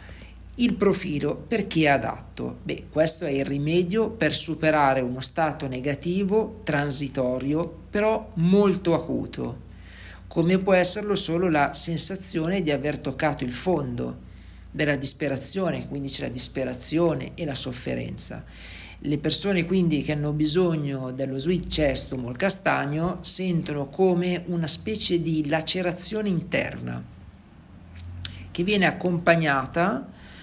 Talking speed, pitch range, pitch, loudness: 120 wpm, 130-180 Hz, 155 Hz, -22 LUFS